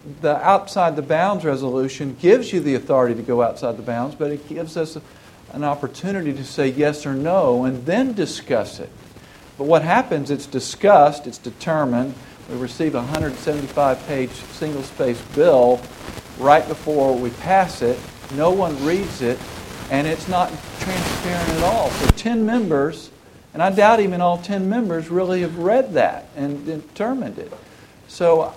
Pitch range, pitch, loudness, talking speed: 130-175 Hz, 150 Hz, -20 LUFS, 160 wpm